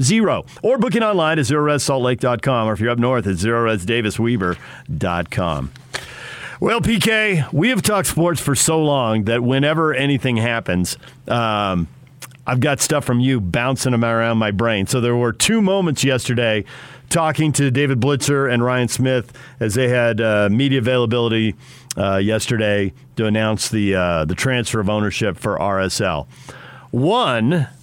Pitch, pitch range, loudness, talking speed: 125 Hz, 110-140 Hz, -18 LUFS, 145 wpm